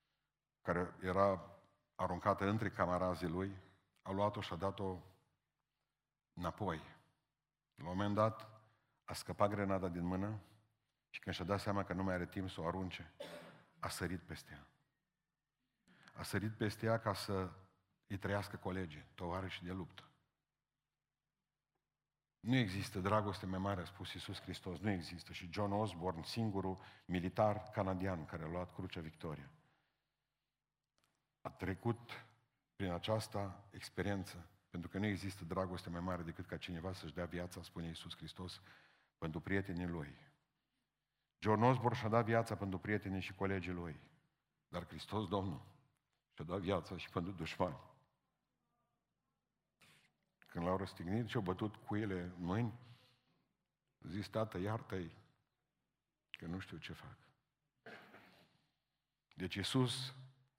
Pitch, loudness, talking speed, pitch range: 100 Hz, -42 LUFS, 135 wpm, 90-110 Hz